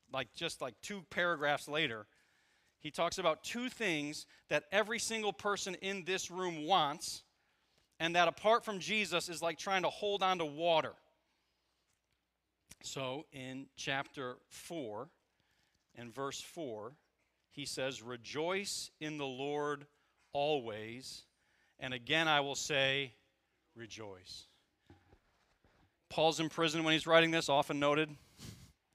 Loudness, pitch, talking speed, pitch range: -35 LUFS, 155 Hz, 125 wpm, 135-175 Hz